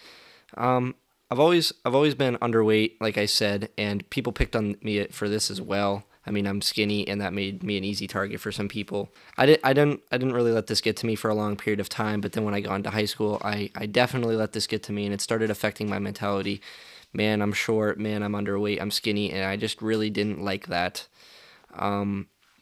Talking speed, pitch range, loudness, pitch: 235 wpm, 100-110 Hz, -26 LUFS, 105 Hz